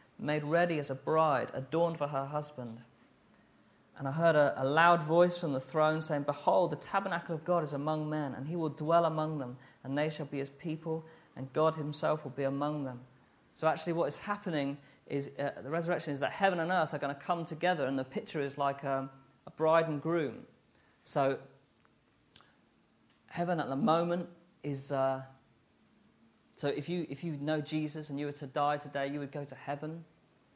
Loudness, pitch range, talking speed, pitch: -33 LUFS, 140-165 Hz, 200 wpm, 150 Hz